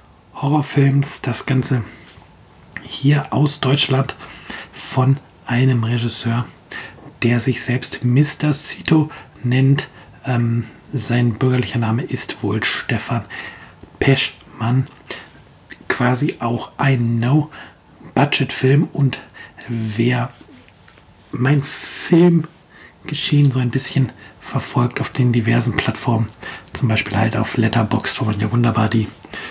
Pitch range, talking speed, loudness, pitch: 115-140 Hz, 100 wpm, -18 LUFS, 125 Hz